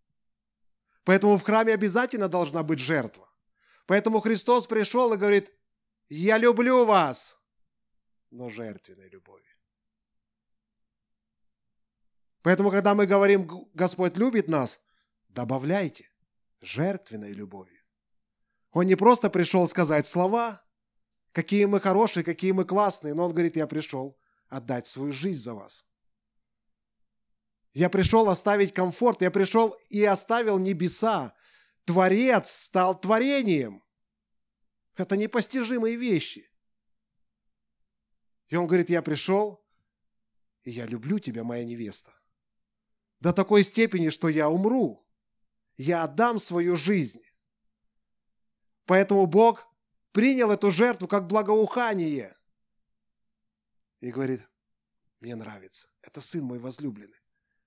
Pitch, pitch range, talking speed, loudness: 180 Hz, 125-205 Hz, 105 wpm, -24 LUFS